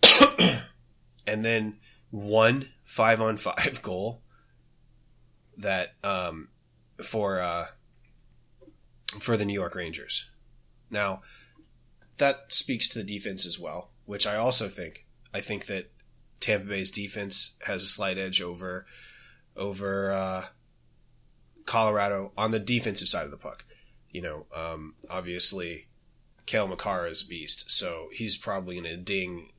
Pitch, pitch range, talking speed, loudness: 100 Hz, 90-110 Hz, 130 wpm, -24 LUFS